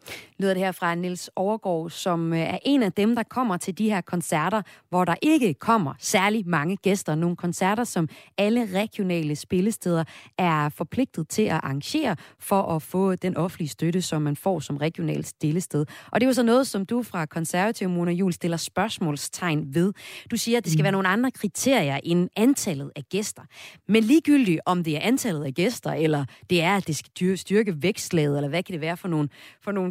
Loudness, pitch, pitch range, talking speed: -24 LUFS, 180 Hz, 160-210 Hz, 200 wpm